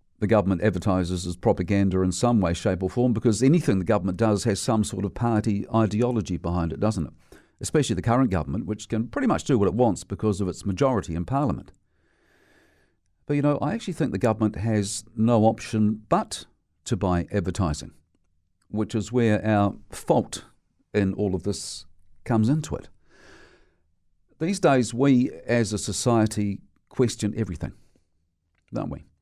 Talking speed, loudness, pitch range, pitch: 165 wpm, -24 LUFS, 90-115 Hz, 105 Hz